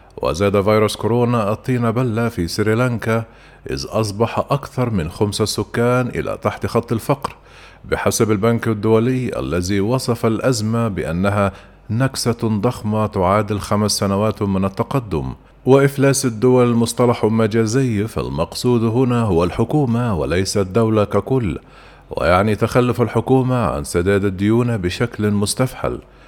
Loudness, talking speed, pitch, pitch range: -18 LUFS, 115 wpm, 115 Hz, 100-120 Hz